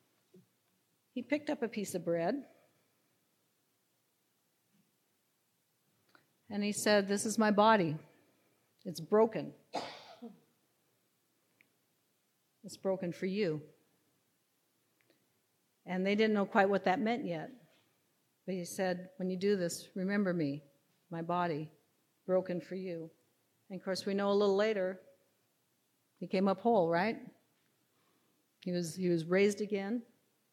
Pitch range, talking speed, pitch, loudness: 175-210 Hz, 120 wpm, 190 Hz, -34 LUFS